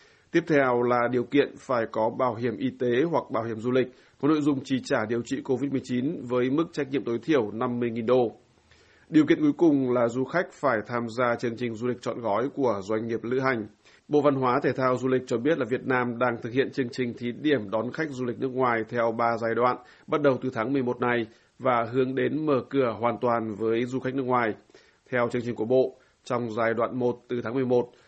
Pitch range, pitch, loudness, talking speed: 120-135 Hz, 125 Hz, -26 LUFS, 240 wpm